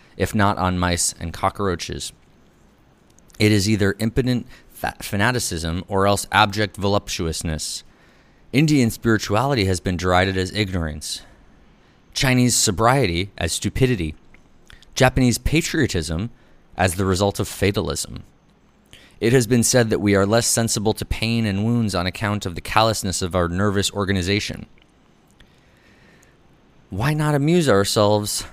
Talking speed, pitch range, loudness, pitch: 125 wpm, 95-115 Hz, -20 LUFS, 100 Hz